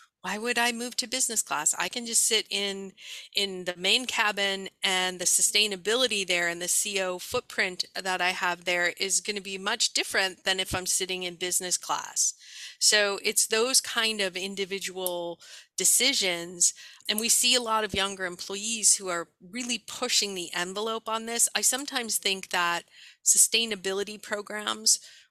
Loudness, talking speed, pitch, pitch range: -25 LUFS, 165 wpm, 195 Hz, 185-220 Hz